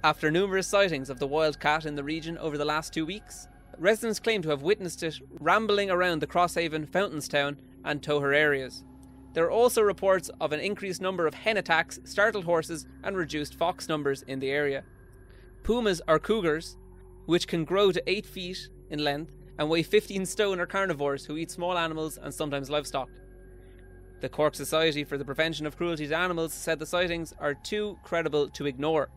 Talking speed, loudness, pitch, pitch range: 185 wpm, -28 LUFS, 160 Hz, 145-180 Hz